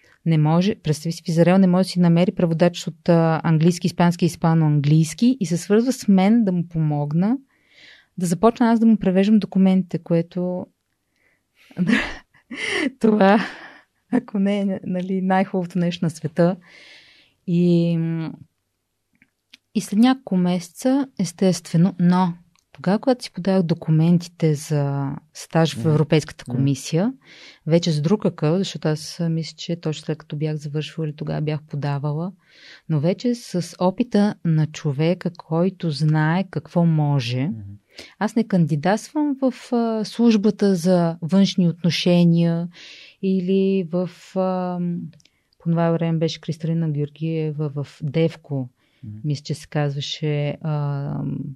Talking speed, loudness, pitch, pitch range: 125 wpm, -21 LUFS, 170 Hz, 155-190 Hz